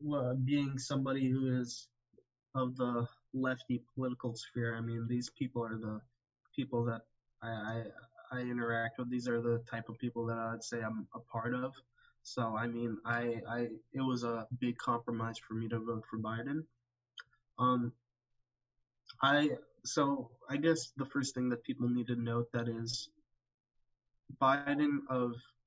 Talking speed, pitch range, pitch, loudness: 165 wpm, 115-130 Hz, 120 Hz, -37 LUFS